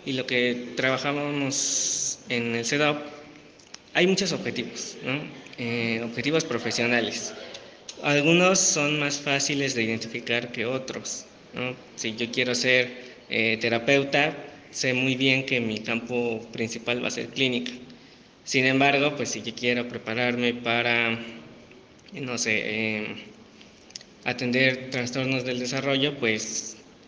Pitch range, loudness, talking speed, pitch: 115-140 Hz, -25 LUFS, 125 wpm, 125 Hz